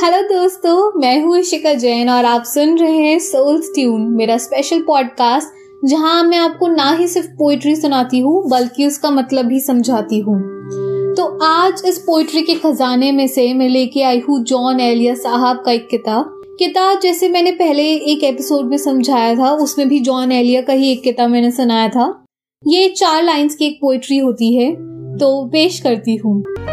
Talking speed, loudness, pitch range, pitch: 175 wpm, -14 LUFS, 245-330 Hz, 275 Hz